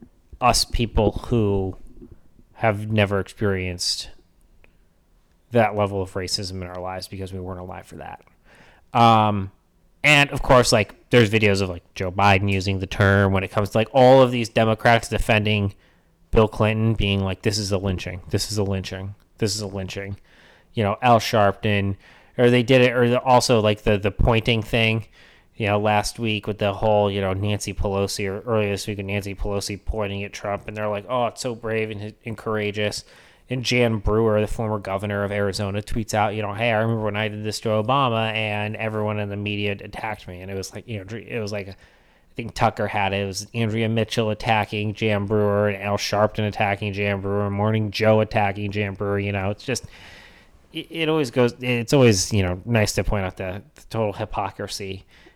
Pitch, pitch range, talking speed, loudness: 105 Hz, 100-110 Hz, 200 wpm, -22 LUFS